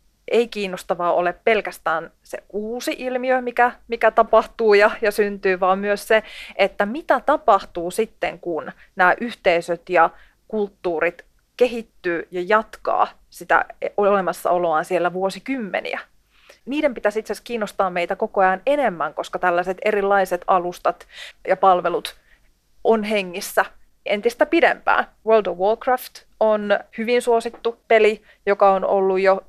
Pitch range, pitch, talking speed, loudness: 190-230 Hz, 205 Hz, 125 wpm, -20 LUFS